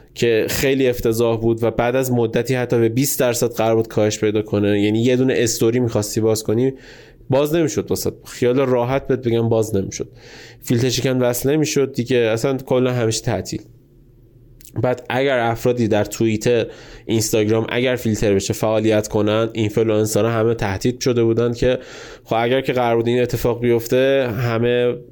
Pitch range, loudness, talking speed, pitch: 110-125 Hz, -18 LUFS, 160 wpm, 120 Hz